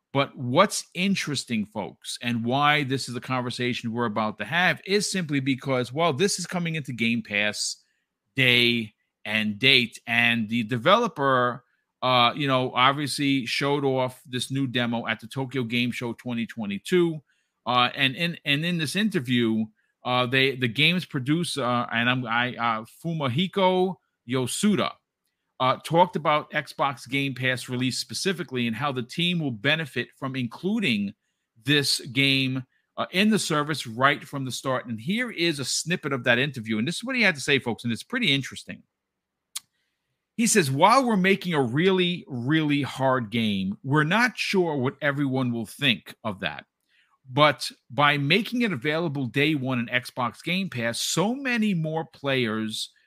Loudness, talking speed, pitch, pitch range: -24 LUFS, 165 wpm, 135 Hz, 120-165 Hz